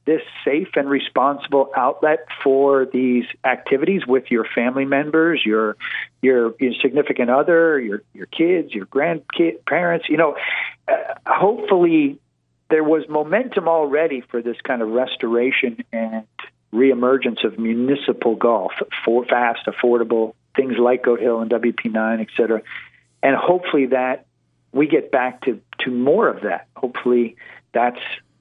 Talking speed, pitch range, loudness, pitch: 140 wpm, 115-155 Hz, -19 LUFS, 130 Hz